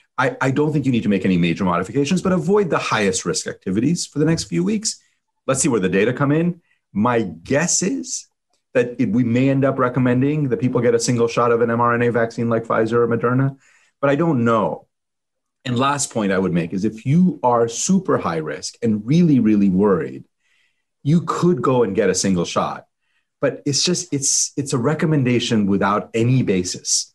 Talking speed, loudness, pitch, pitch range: 205 wpm, -19 LUFS, 130 Hz, 115-155 Hz